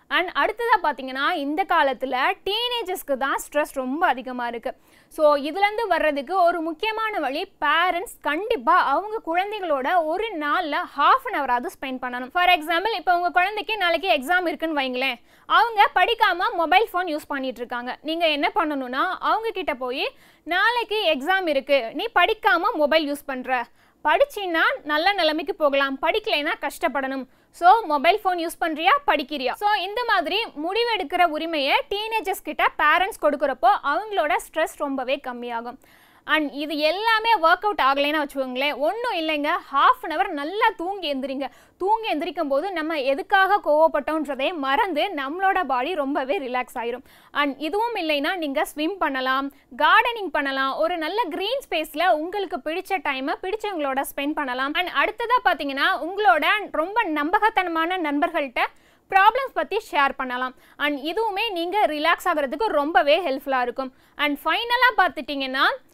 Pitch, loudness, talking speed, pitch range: 330 Hz, -22 LUFS, 135 wpm, 285-385 Hz